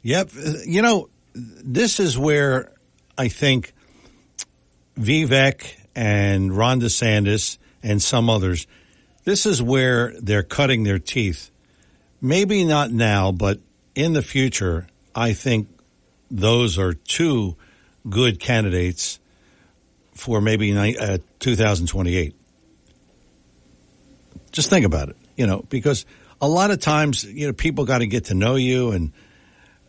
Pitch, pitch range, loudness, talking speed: 115 Hz, 95-135 Hz, -20 LUFS, 120 wpm